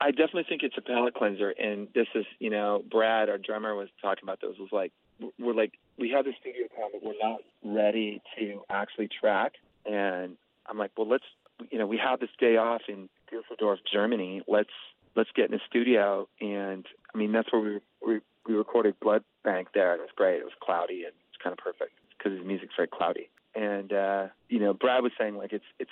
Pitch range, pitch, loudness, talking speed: 100-120 Hz, 110 Hz, -30 LUFS, 220 wpm